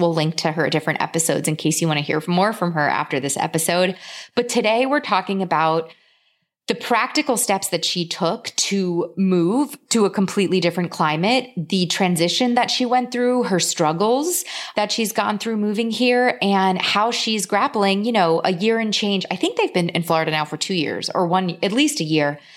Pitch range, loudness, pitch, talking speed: 165-225 Hz, -20 LUFS, 190 Hz, 200 wpm